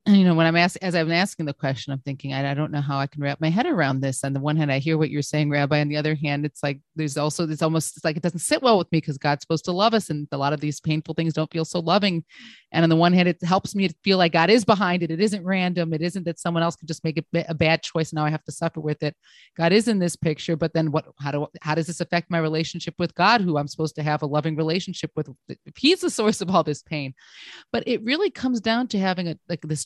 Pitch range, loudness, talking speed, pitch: 150-180 Hz, -23 LUFS, 305 wpm, 165 Hz